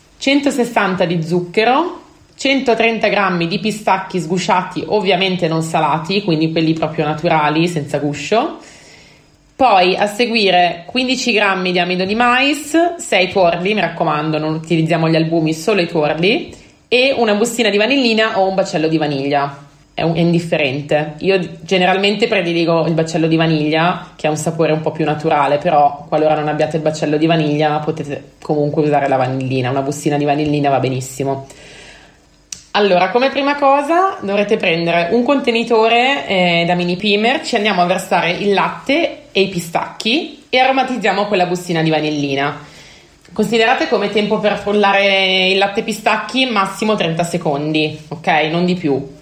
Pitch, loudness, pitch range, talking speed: 180 Hz, -15 LUFS, 155-215 Hz, 155 wpm